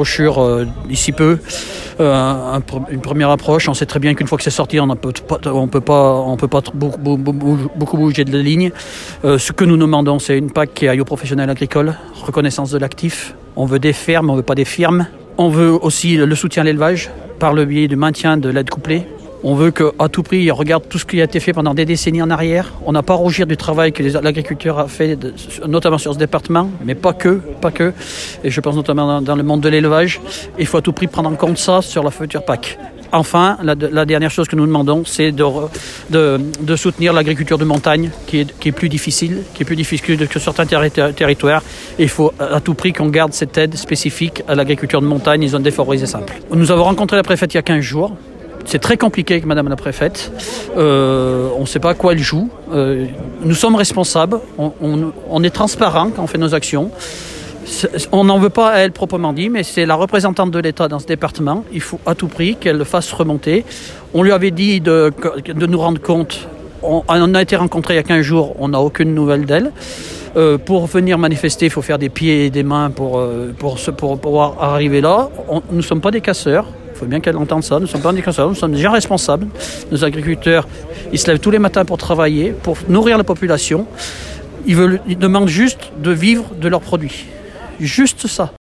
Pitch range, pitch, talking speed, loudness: 145-170 Hz, 155 Hz, 230 wpm, -14 LUFS